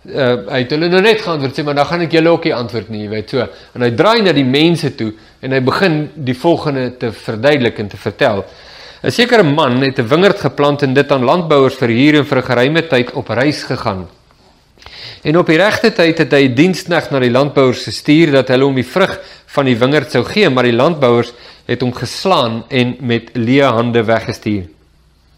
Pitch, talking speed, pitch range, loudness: 135 Hz, 210 wpm, 120-150 Hz, -13 LUFS